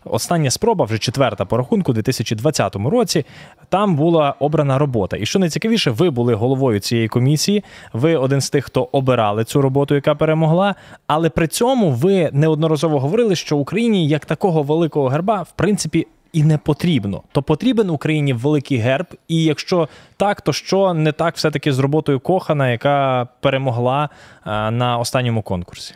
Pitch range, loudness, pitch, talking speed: 130-165 Hz, -17 LUFS, 150 Hz, 160 wpm